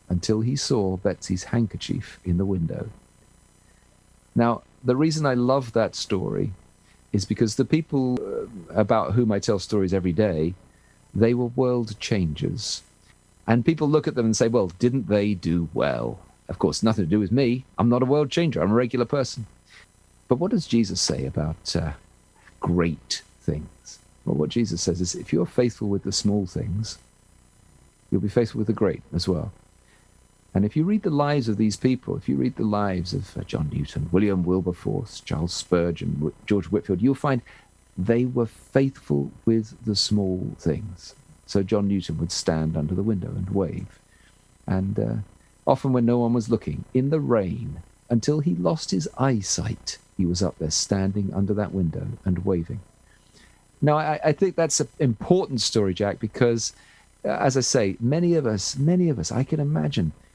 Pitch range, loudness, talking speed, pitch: 90-125 Hz, -24 LUFS, 175 wpm, 105 Hz